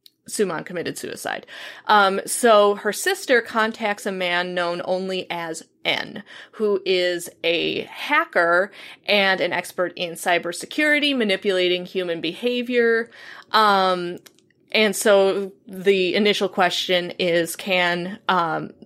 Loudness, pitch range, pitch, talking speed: -21 LUFS, 180-215 Hz, 195 Hz, 110 wpm